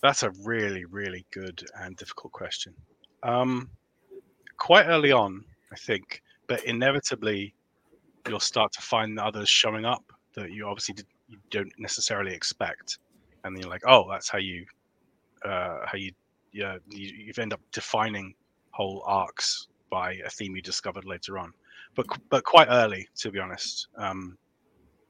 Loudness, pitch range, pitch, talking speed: -26 LUFS, 95-115 Hz, 100 Hz, 155 wpm